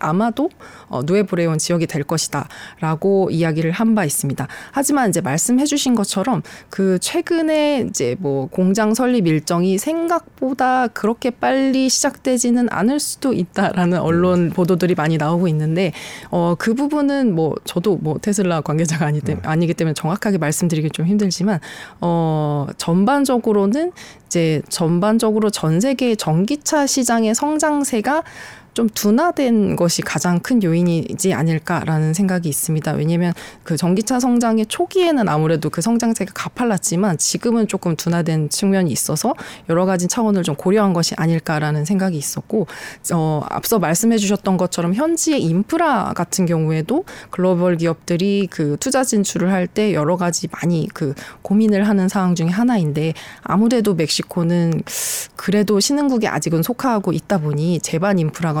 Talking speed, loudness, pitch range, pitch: 345 characters per minute, -18 LUFS, 165-230 Hz, 185 Hz